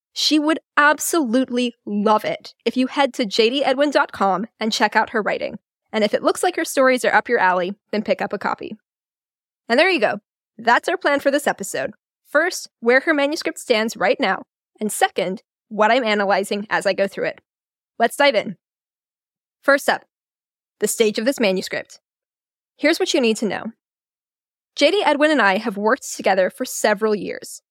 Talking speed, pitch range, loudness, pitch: 180 wpm, 210-290 Hz, -19 LUFS, 240 Hz